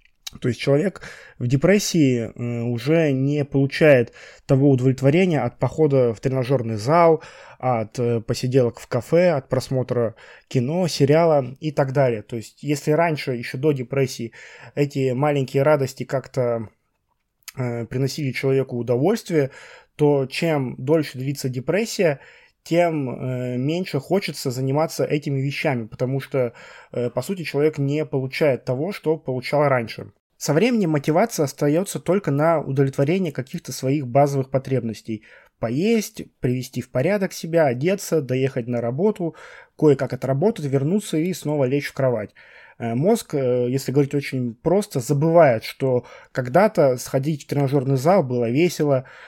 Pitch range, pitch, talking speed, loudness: 125-160 Hz, 140 Hz, 125 wpm, -21 LUFS